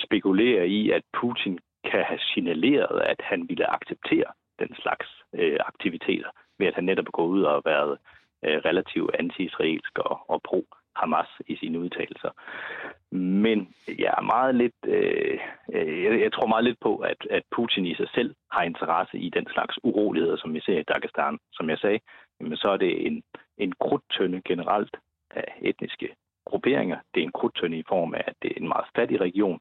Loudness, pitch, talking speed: -26 LUFS, 370 Hz, 185 wpm